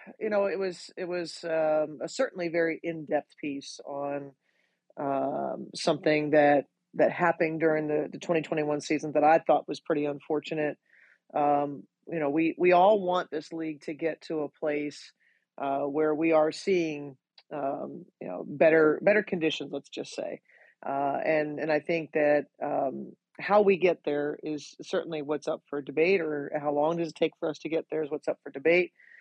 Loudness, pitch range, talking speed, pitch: -28 LUFS, 145-165 Hz, 185 wpm, 155 Hz